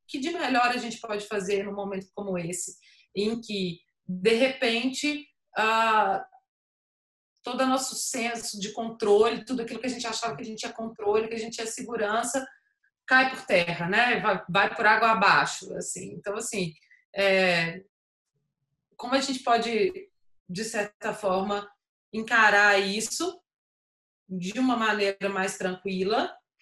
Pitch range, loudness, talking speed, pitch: 195-245 Hz, -26 LUFS, 145 wpm, 220 Hz